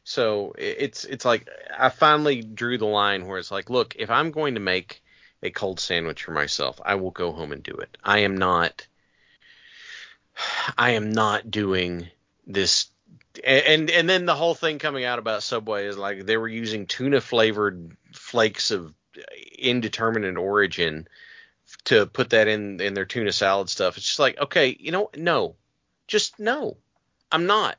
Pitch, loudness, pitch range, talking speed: 115 Hz, -23 LUFS, 100-160 Hz, 170 wpm